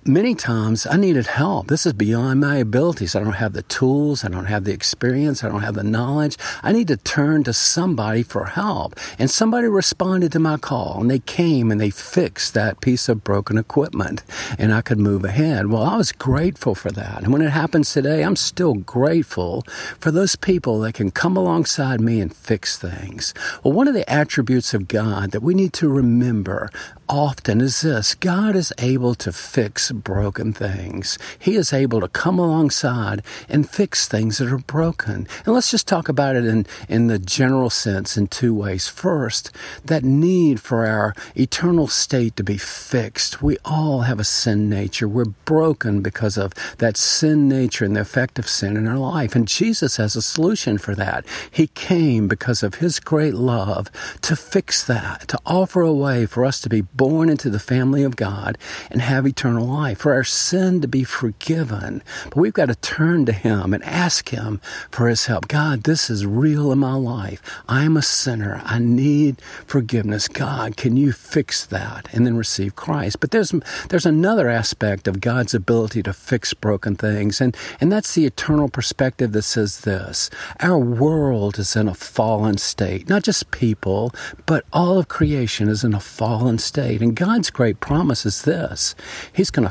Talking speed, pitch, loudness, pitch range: 190 wpm, 125 Hz, -19 LUFS, 110-150 Hz